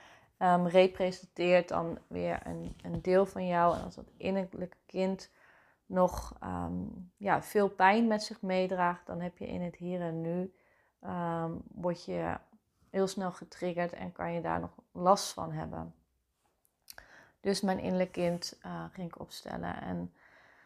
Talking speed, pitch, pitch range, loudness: 155 wpm, 180 Hz, 165-185 Hz, -33 LUFS